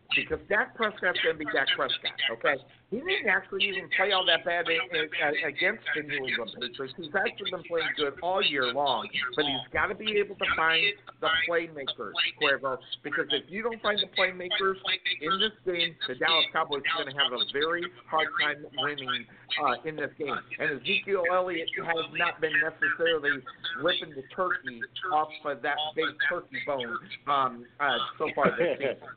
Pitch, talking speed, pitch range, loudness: 175 Hz, 185 wpm, 155-195 Hz, -28 LUFS